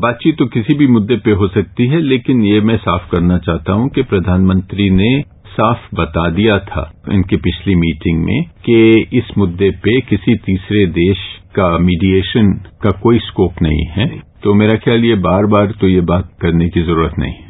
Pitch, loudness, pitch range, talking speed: 100 Hz, -13 LUFS, 90-115 Hz, 190 wpm